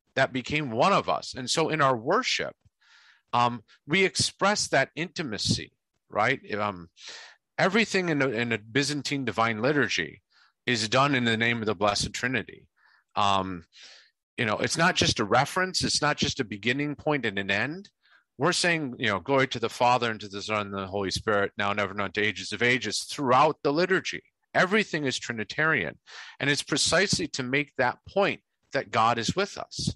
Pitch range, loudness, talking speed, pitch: 105-150 Hz, -26 LUFS, 185 wpm, 130 Hz